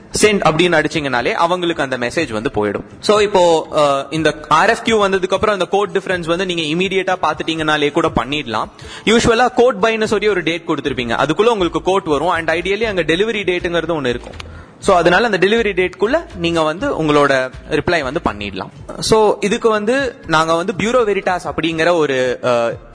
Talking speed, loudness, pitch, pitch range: 165 wpm, -16 LUFS, 170 Hz, 150-200 Hz